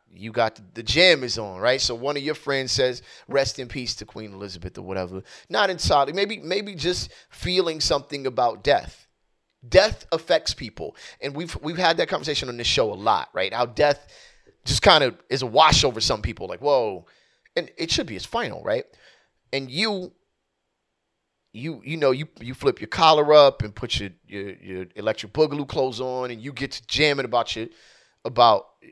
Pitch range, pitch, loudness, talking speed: 110-150 Hz, 130 Hz, -22 LUFS, 195 wpm